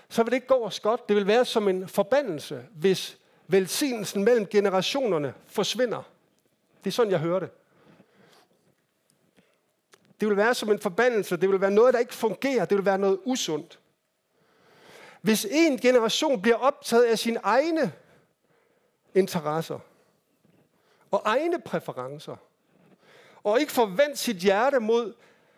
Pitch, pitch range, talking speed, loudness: 220 Hz, 195-255 Hz, 140 wpm, -25 LUFS